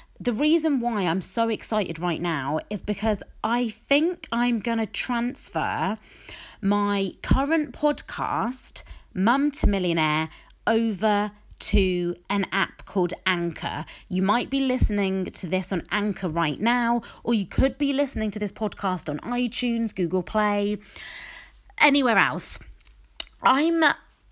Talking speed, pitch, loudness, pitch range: 130 wpm, 210 Hz, -25 LUFS, 185-245 Hz